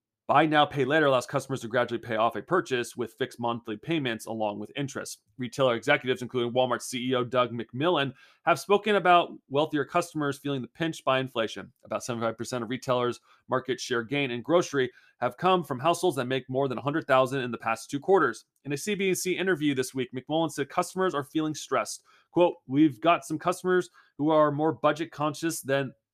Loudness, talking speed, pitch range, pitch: -27 LUFS, 190 wpm, 125-160 Hz, 140 Hz